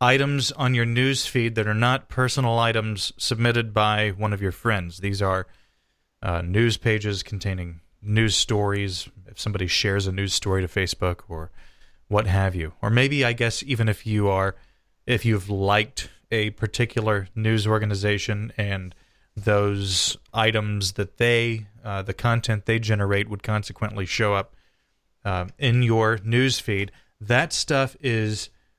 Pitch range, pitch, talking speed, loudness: 95-115 Hz, 105 Hz, 150 wpm, -23 LUFS